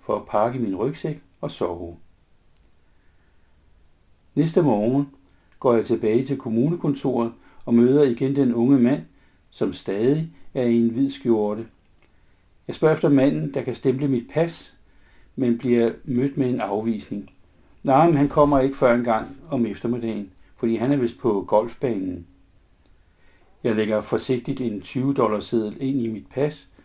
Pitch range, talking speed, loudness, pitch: 95-135 Hz, 150 wpm, -22 LUFS, 115 Hz